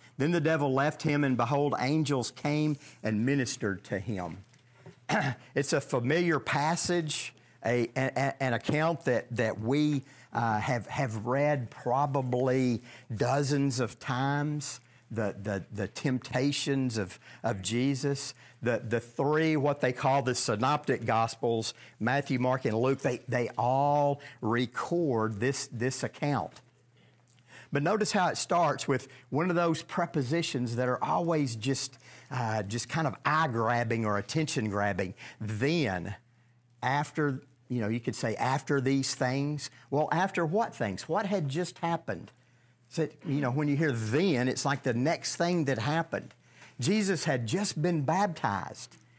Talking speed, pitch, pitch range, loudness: 145 wpm, 130 Hz, 120-150 Hz, -30 LUFS